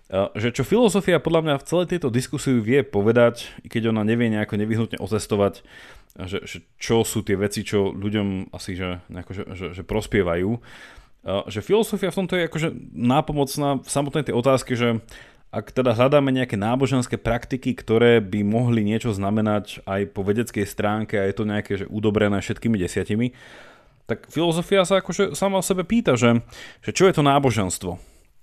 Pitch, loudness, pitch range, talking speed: 115 Hz, -22 LUFS, 105-140 Hz, 175 wpm